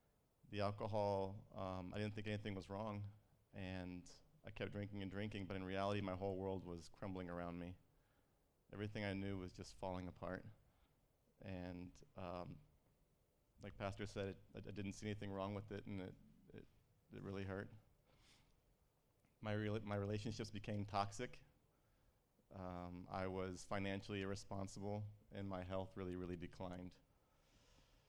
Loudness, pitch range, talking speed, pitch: -49 LUFS, 95-105 Hz, 145 wpm, 100 Hz